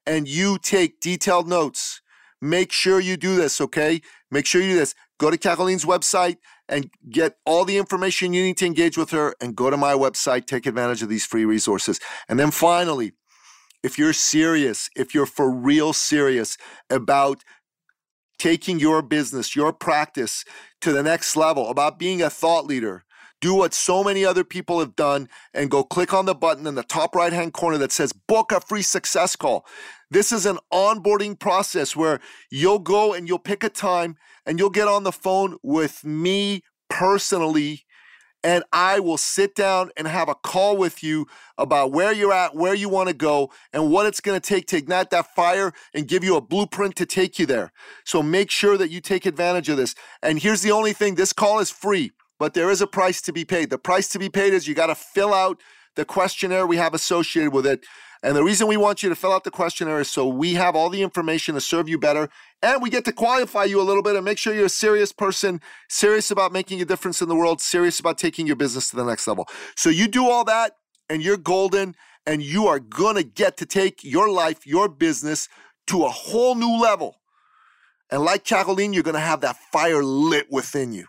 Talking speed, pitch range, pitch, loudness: 215 wpm, 155-195 Hz, 180 Hz, -21 LUFS